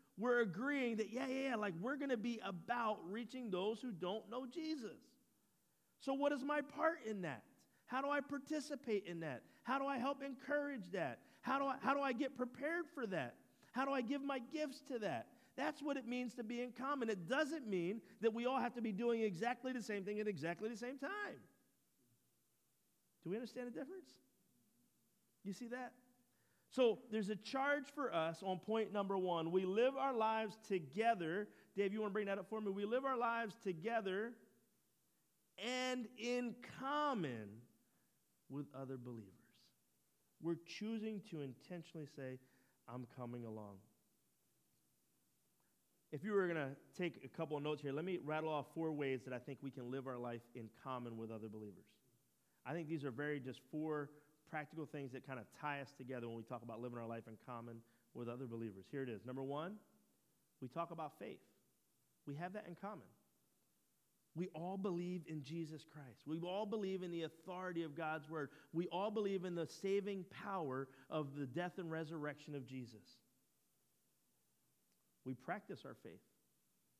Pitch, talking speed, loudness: 185 Hz, 185 wpm, -44 LUFS